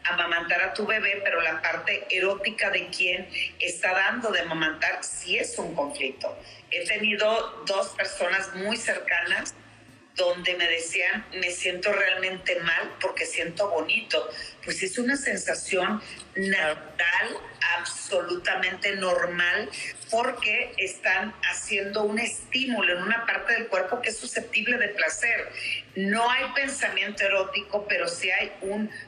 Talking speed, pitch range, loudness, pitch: 135 wpm, 175-215 Hz, -25 LUFS, 195 Hz